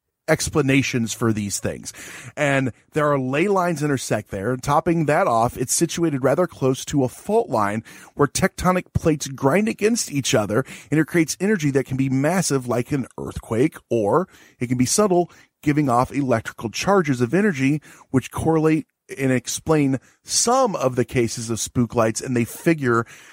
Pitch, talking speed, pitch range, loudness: 135 Hz, 170 wpm, 125-160 Hz, -21 LUFS